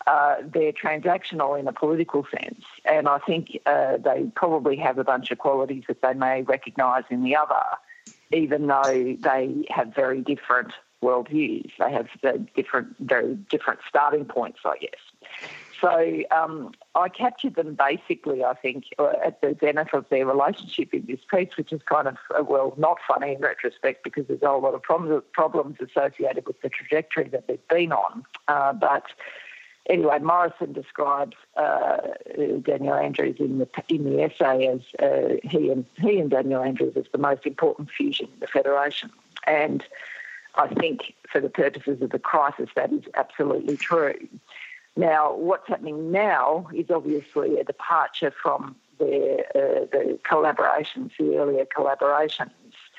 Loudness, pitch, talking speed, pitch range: -24 LUFS, 155 Hz, 160 wpm, 140-225 Hz